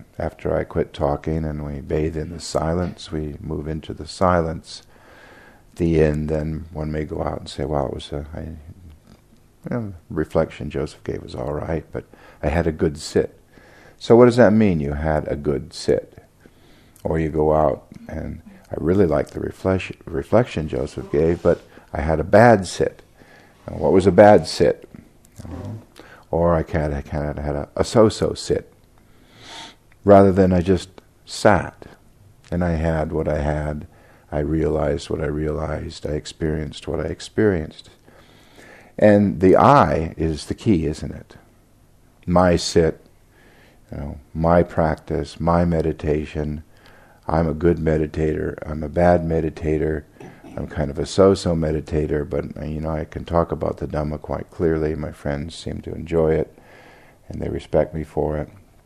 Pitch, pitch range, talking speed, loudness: 80 Hz, 75-90 Hz, 165 wpm, -20 LUFS